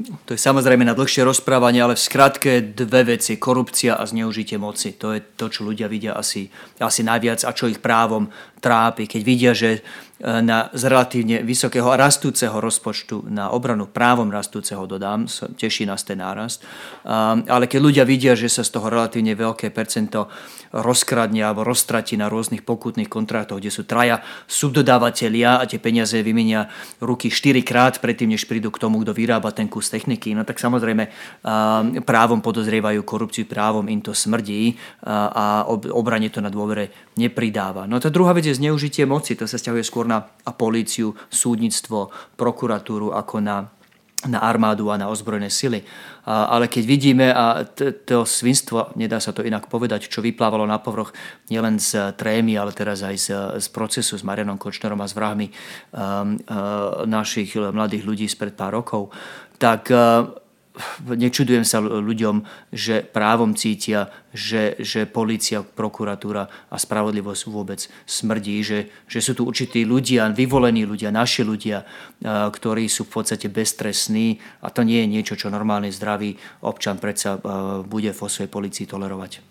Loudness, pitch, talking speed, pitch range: -20 LUFS, 110 Hz, 160 wpm, 105-120 Hz